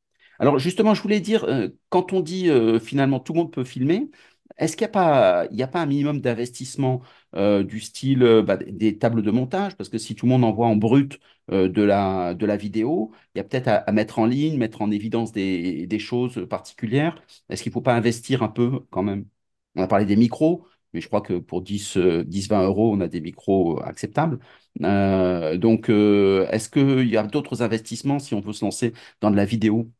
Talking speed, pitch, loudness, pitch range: 220 wpm, 115 Hz, -22 LUFS, 105-140 Hz